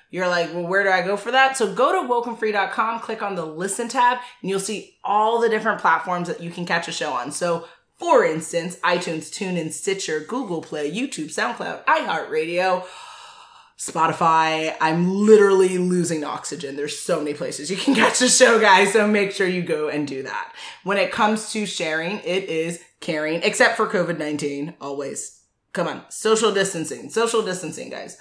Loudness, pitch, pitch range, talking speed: -21 LUFS, 185 Hz, 165-220 Hz, 180 wpm